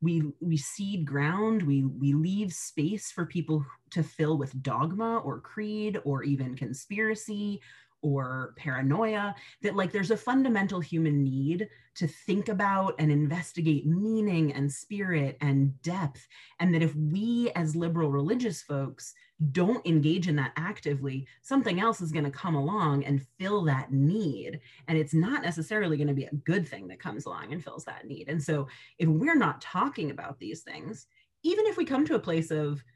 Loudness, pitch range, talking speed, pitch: -29 LUFS, 145-200 Hz, 175 wpm, 160 Hz